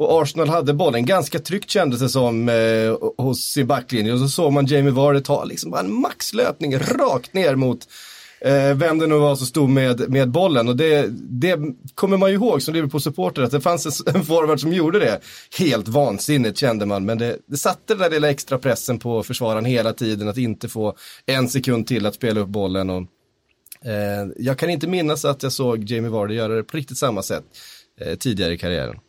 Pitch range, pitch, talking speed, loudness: 115-150 Hz, 130 Hz, 210 wpm, -20 LUFS